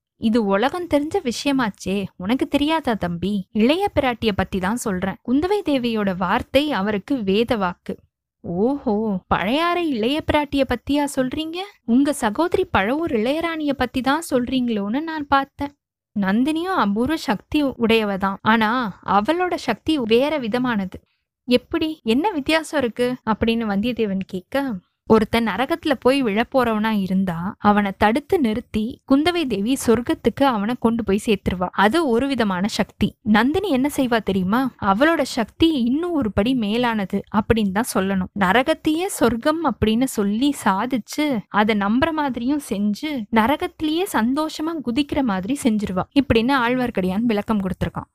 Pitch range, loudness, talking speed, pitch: 210-285 Hz, -21 LUFS, 125 wpm, 240 Hz